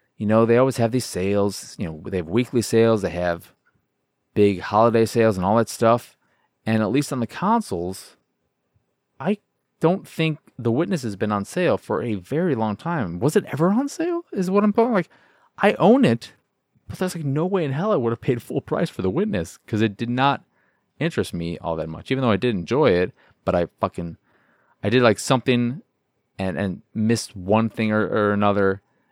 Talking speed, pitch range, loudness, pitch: 210 wpm, 100-145 Hz, -22 LUFS, 115 Hz